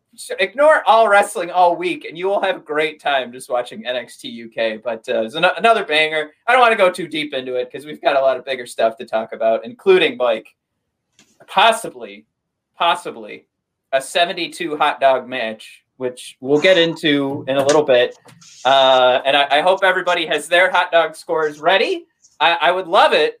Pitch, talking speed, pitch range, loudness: 155 Hz, 195 wpm, 130-190 Hz, -16 LUFS